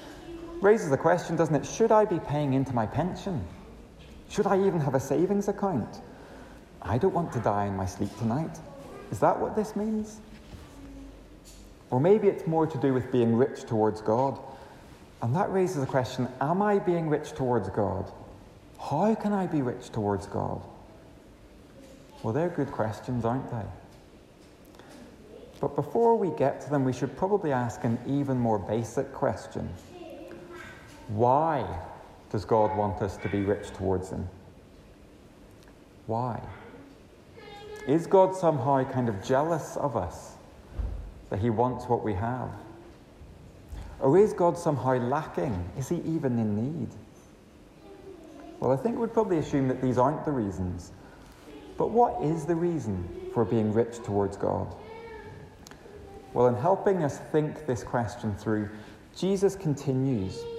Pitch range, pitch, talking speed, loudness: 110-175 Hz, 130 Hz, 150 wpm, -28 LUFS